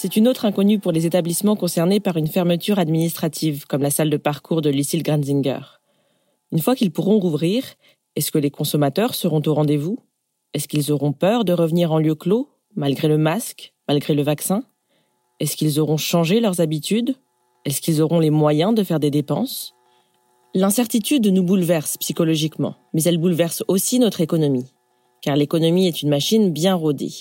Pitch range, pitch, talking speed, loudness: 150-190 Hz, 165 Hz, 175 wpm, -19 LUFS